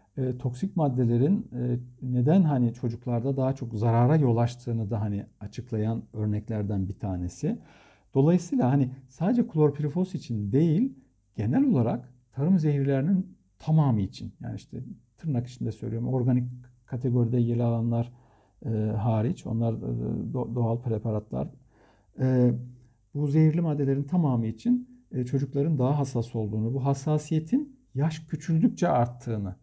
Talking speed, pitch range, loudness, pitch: 125 wpm, 115-145 Hz, -27 LUFS, 125 Hz